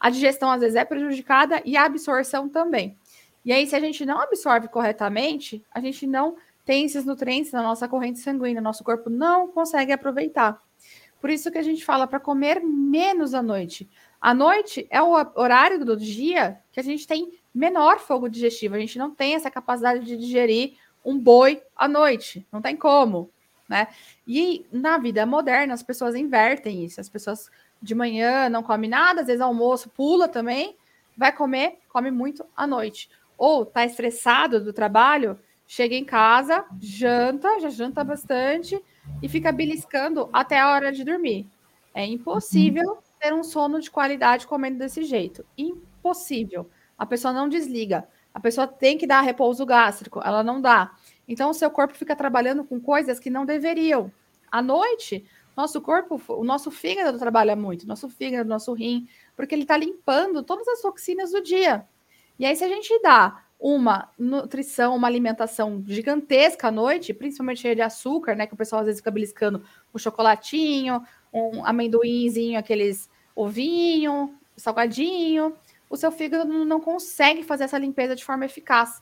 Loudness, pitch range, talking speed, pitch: -22 LUFS, 235-300 Hz, 170 wpm, 265 Hz